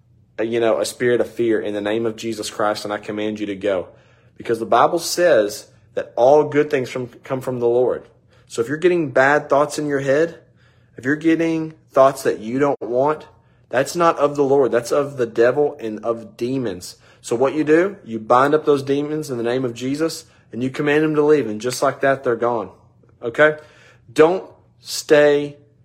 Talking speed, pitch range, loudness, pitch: 205 wpm, 115-150 Hz, -19 LUFS, 130 Hz